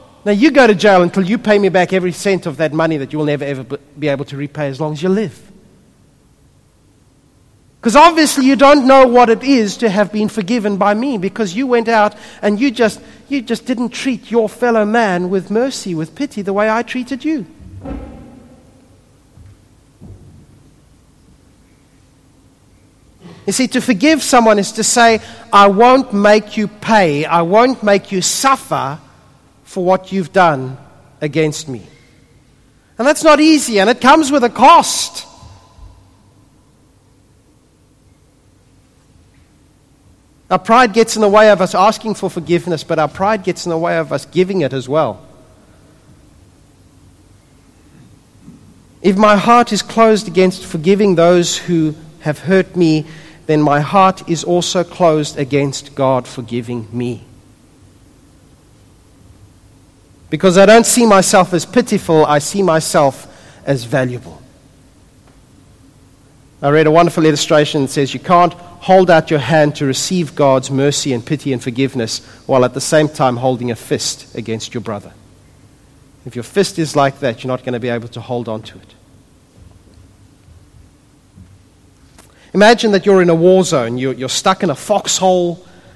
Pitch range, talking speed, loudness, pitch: 130-210 Hz, 155 wpm, -13 LUFS, 170 Hz